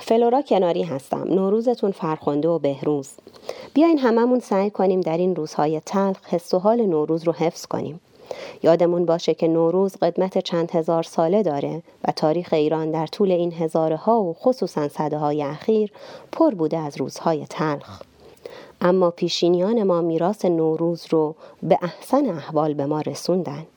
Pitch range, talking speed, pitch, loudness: 160-210 Hz, 155 wpm, 175 Hz, -21 LUFS